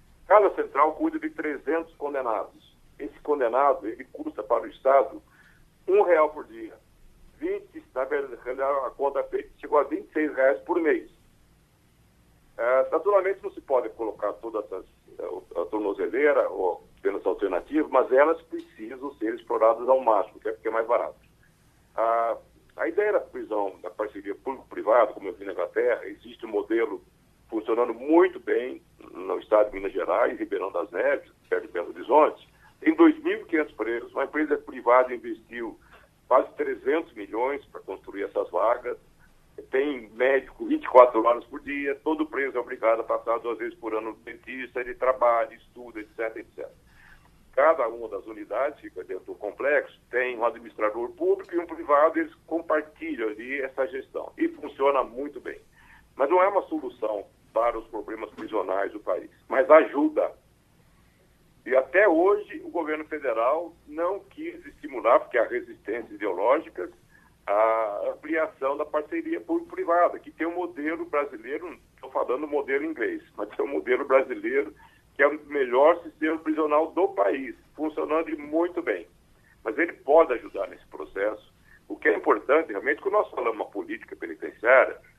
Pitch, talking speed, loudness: 340 Hz, 155 wpm, -26 LUFS